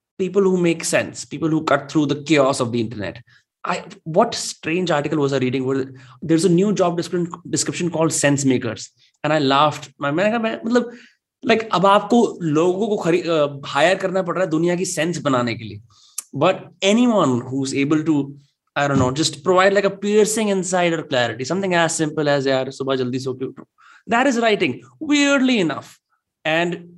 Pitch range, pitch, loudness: 140-190 Hz, 160 Hz, -19 LUFS